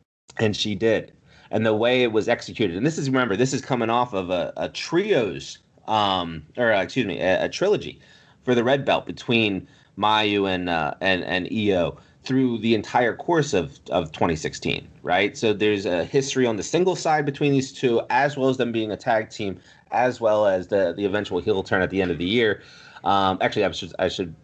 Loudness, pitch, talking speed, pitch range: -23 LUFS, 110 Hz, 215 wpm, 100-125 Hz